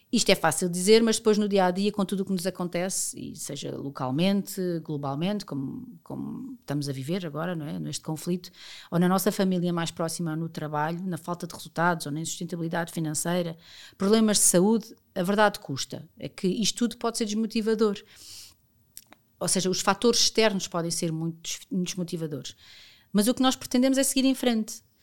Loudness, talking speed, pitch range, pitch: -26 LUFS, 185 wpm, 160-210 Hz, 180 Hz